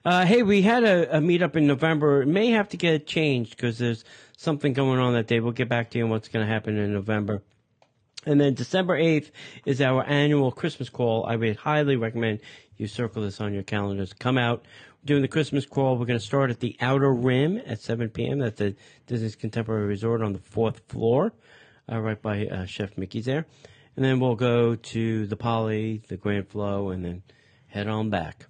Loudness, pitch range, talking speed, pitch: -25 LUFS, 110-140 Hz, 215 wpm, 120 Hz